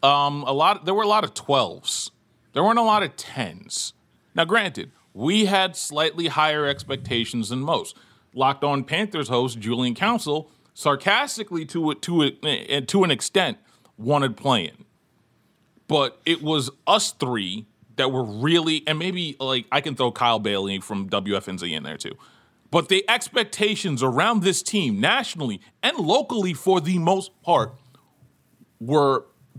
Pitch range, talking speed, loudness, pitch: 130-190 Hz, 150 wpm, -22 LUFS, 150 Hz